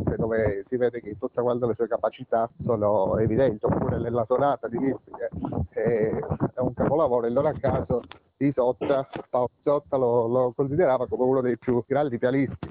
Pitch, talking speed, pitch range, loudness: 125 Hz, 175 wpm, 120-130 Hz, -25 LUFS